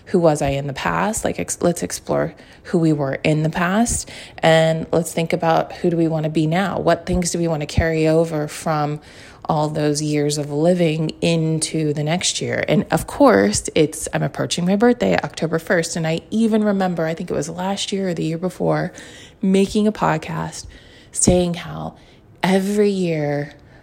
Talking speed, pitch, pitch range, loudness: 190 wpm, 165 Hz, 155-180 Hz, -19 LUFS